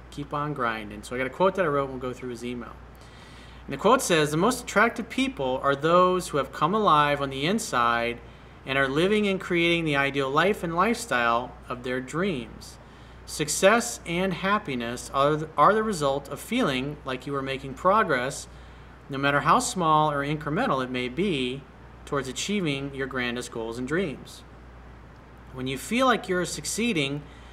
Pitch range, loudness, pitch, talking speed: 125-180 Hz, -25 LUFS, 140 Hz, 180 wpm